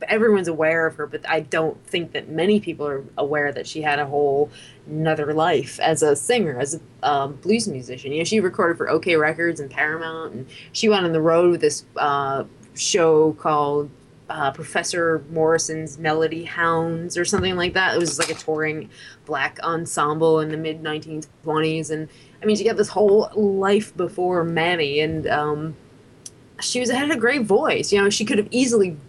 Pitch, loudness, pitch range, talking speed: 160 Hz, -21 LUFS, 150-175 Hz, 190 wpm